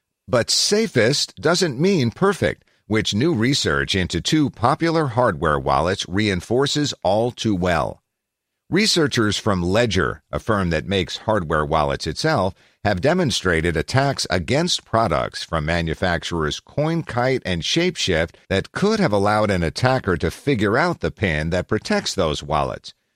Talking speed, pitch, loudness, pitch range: 135 wpm, 105 Hz, -20 LUFS, 85-145 Hz